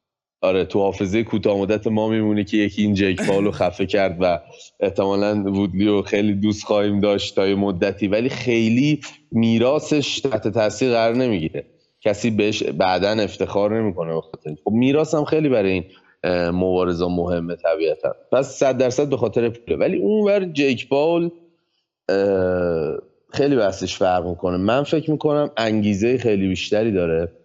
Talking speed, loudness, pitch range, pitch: 155 wpm, -20 LUFS, 95-125 Hz, 105 Hz